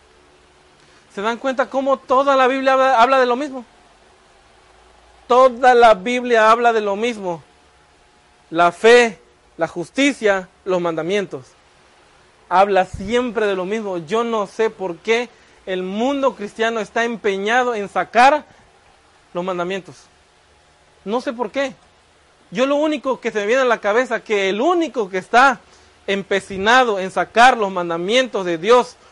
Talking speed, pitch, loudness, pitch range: 140 wpm, 220 Hz, -17 LUFS, 185-250 Hz